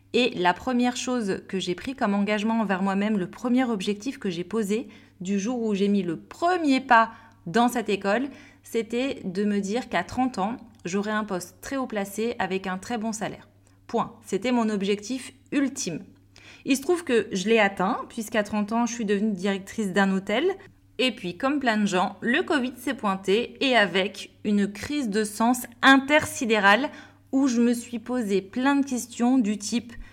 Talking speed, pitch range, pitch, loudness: 185 wpm, 195-250 Hz, 225 Hz, -25 LUFS